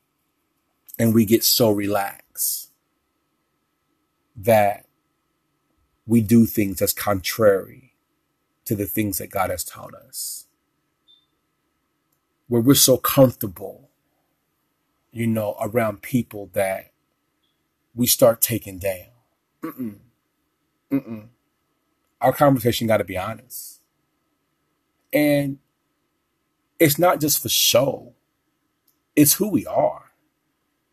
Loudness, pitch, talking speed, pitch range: -20 LUFS, 115 Hz, 95 wpm, 105-140 Hz